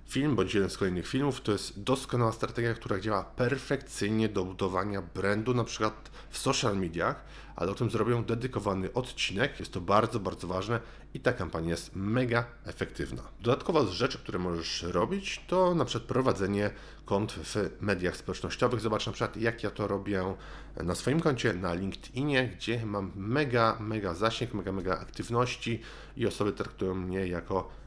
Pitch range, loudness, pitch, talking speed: 95-125 Hz, -31 LUFS, 110 Hz, 165 wpm